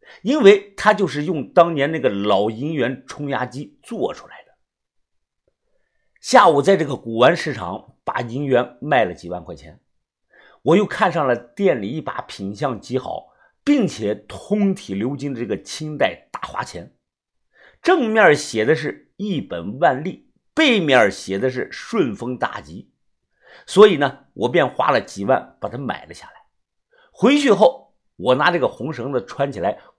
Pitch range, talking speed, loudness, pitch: 125-205 Hz, 220 characters per minute, -19 LUFS, 145 Hz